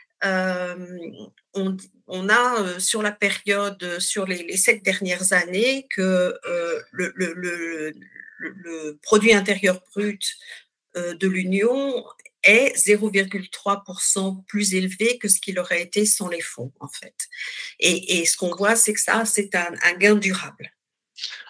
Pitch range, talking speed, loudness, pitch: 180-210 Hz, 150 wpm, -20 LUFS, 190 Hz